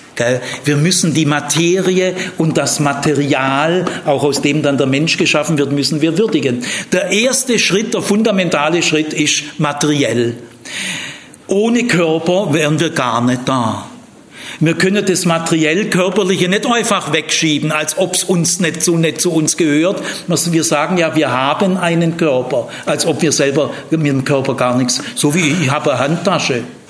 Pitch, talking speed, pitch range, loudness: 160 Hz, 165 wpm, 145-185 Hz, -14 LUFS